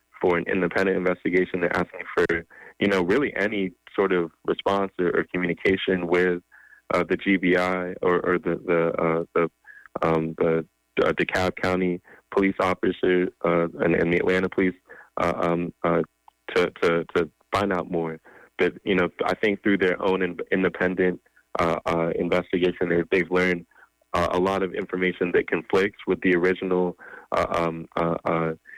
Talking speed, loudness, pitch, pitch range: 165 wpm, -24 LUFS, 90 Hz, 85-95 Hz